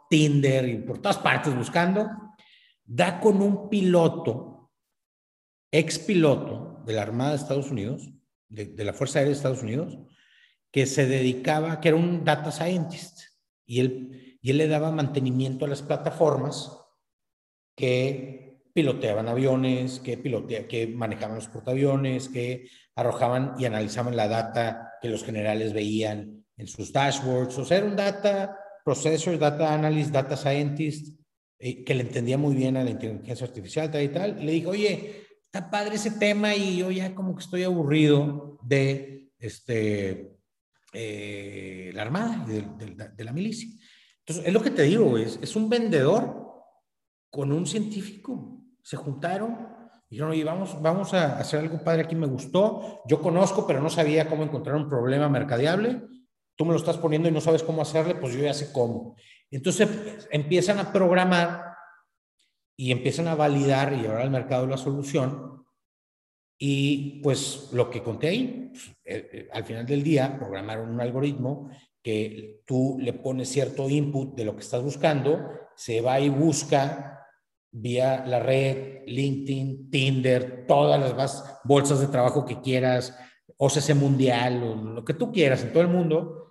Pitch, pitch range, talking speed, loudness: 140 Hz, 125-165 Hz, 160 wpm, -25 LUFS